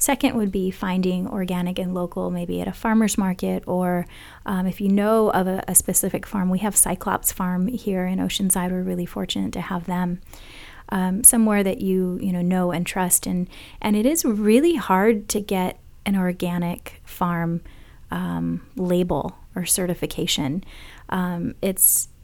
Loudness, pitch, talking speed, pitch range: -21 LUFS, 185 Hz, 165 wpm, 180-200 Hz